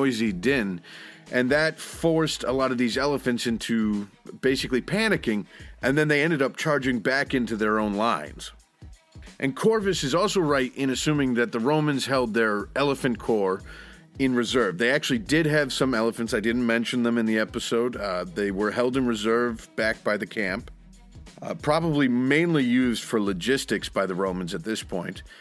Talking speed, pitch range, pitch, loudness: 175 wpm, 115-145 Hz, 125 Hz, -25 LUFS